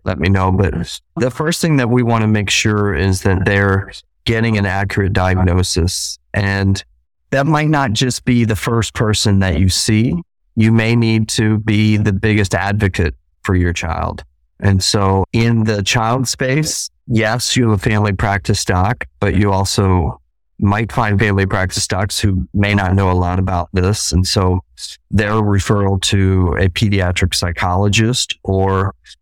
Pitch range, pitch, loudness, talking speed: 95-110 Hz, 100 Hz, -15 LUFS, 165 wpm